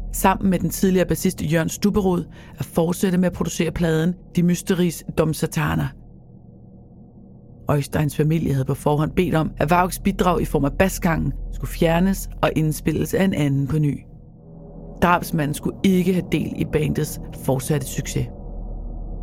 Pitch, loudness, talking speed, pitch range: 165 Hz, -21 LUFS, 155 wpm, 150-180 Hz